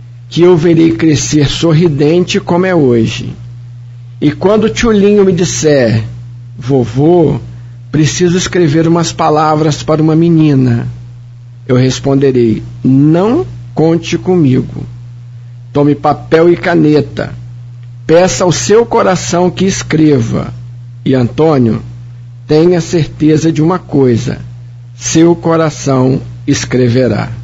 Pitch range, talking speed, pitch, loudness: 120-165 Hz, 105 wpm, 140 Hz, -10 LUFS